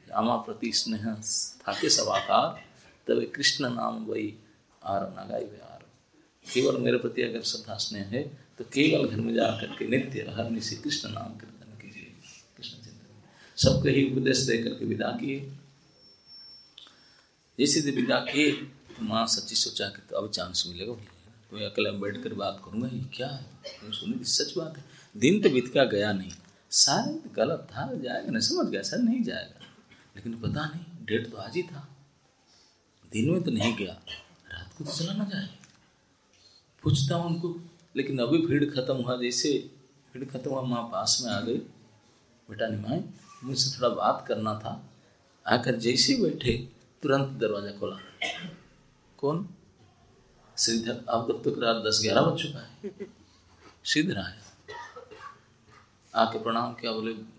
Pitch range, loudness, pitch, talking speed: 110-145 Hz, -28 LUFS, 125 Hz, 155 wpm